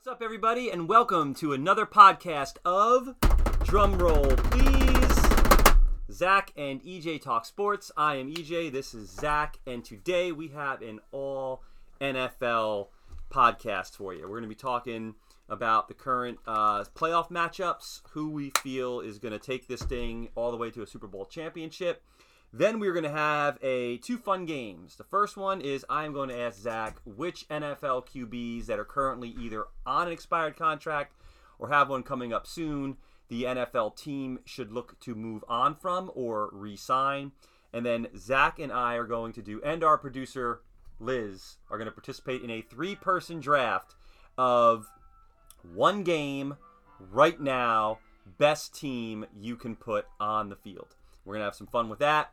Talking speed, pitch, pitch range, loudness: 170 wpm, 130 Hz, 115-155 Hz, -28 LUFS